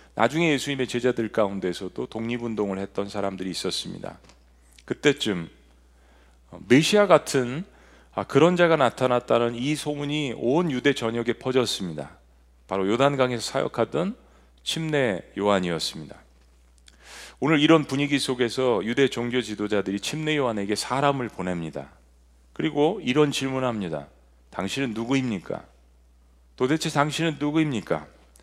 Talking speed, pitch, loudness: 305 characters per minute, 115 Hz, -24 LUFS